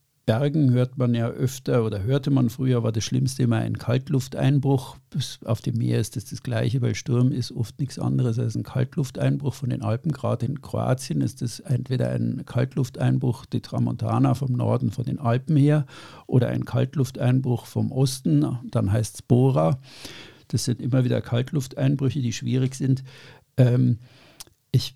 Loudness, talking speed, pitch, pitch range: -24 LUFS, 170 wpm, 130 Hz, 120-135 Hz